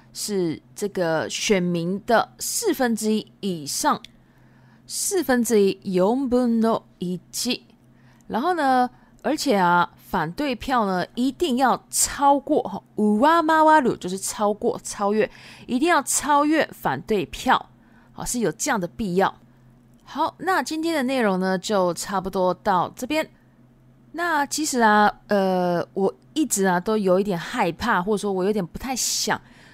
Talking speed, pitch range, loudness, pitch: 210 characters per minute, 185-270 Hz, -22 LUFS, 210 Hz